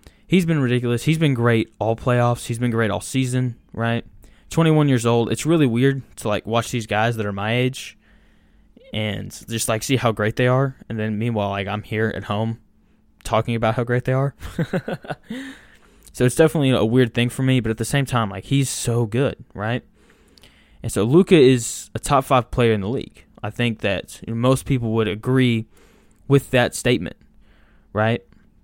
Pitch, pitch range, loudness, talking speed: 120 Hz, 110-130 Hz, -20 LUFS, 200 wpm